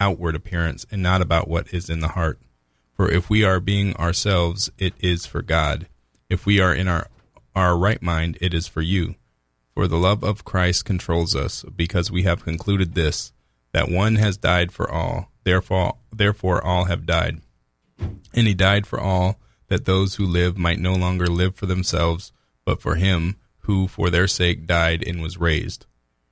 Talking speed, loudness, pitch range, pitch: 185 wpm, -21 LUFS, 85-95 Hz, 90 Hz